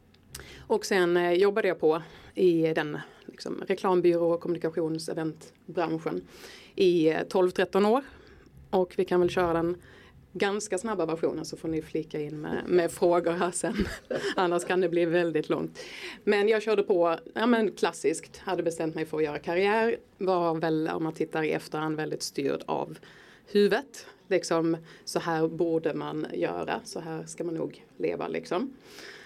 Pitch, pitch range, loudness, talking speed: 175 Hz, 160-195 Hz, -28 LUFS, 160 wpm